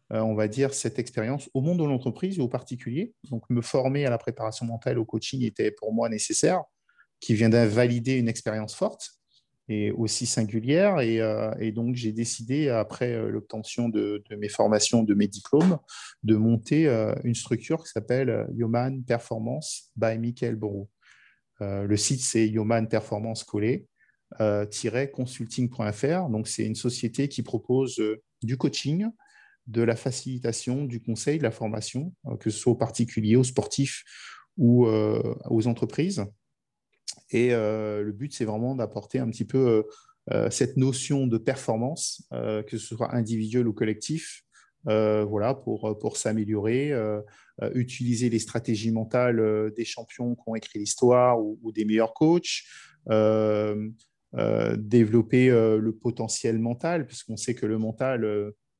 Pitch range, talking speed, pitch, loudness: 110-130 Hz, 155 wpm, 115 Hz, -26 LUFS